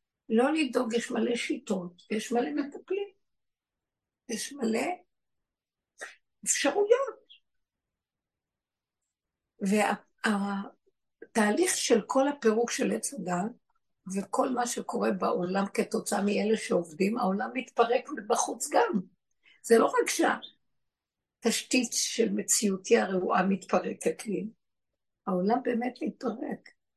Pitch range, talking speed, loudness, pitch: 205-260 Hz, 95 wpm, -29 LUFS, 235 Hz